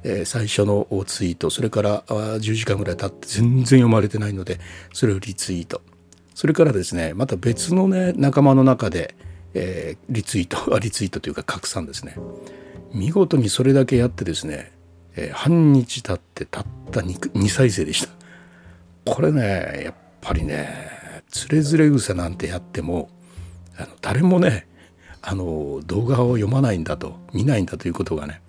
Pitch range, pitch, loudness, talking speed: 85-130 Hz, 100 Hz, -21 LUFS, 320 characters per minute